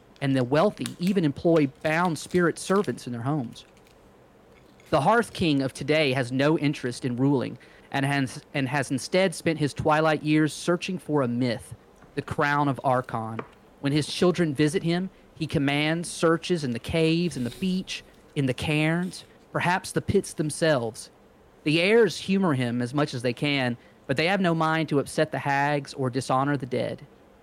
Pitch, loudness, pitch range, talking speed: 150 Hz, -25 LUFS, 130-165 Hz, 175 wpm